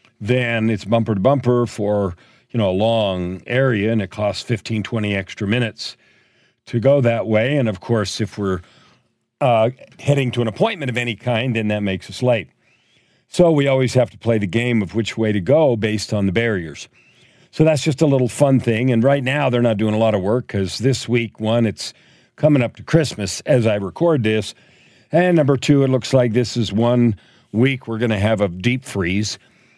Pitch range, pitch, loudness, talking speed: 105-130 Hz, 115 Hz, -18 LUFS, 210 wpm